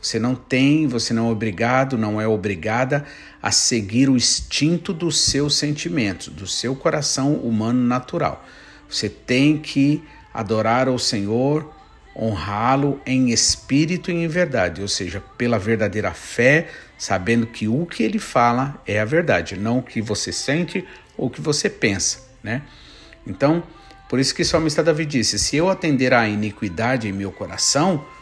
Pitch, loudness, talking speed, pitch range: 125 Hz, -20 LUFS, 155 wpm, 110-150 Hz